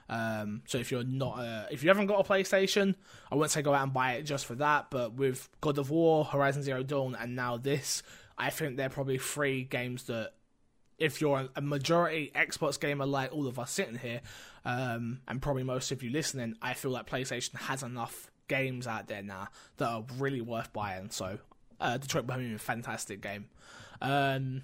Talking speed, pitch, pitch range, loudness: 210 wpm, 130 Hz, 120-145 Hz, -33 LUFS